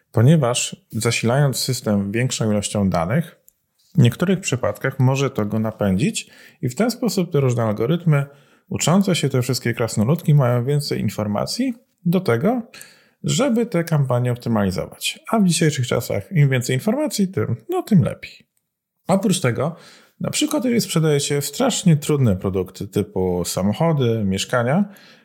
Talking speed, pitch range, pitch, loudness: 140 wpm, 115-185 Hz, 140 Hz, -20 LUFS